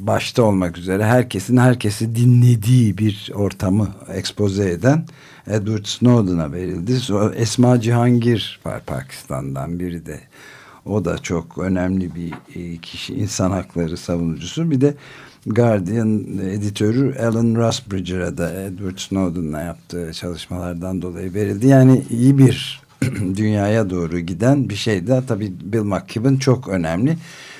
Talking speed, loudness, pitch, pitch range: 115 wpm, -19 LUFS, 105 Hz, 90-120 Hz